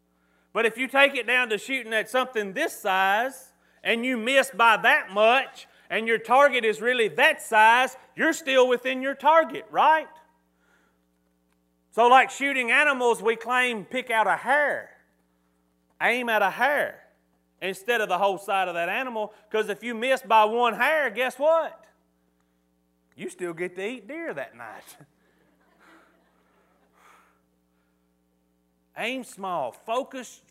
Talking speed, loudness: 145 wpm, -23 LUFS